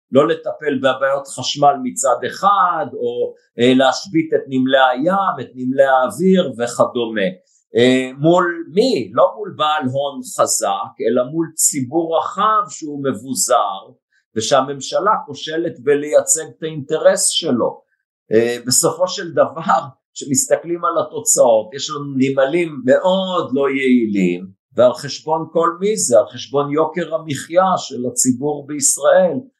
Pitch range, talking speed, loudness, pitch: 130-180 Hz, 125 wpm, -17 LUFS, 150 Hz